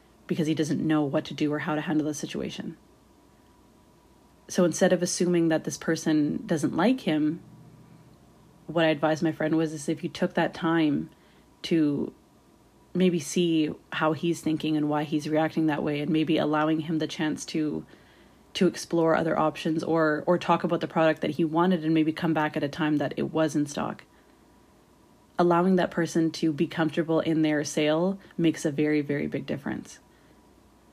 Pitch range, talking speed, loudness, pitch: 155-170 Hz, 180 wpm, -26 LUFS, 160 Hz